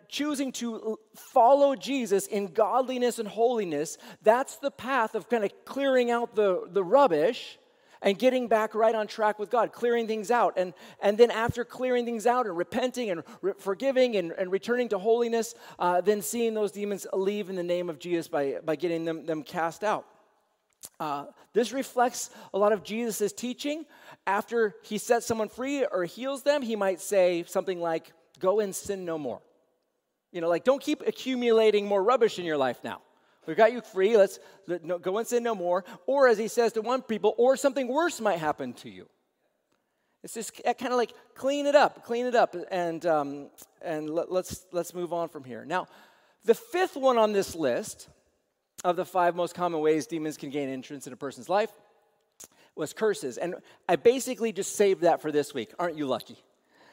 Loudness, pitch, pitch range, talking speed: -27 LUFS, 215 Hz, 180-240 Hz, 195 wpm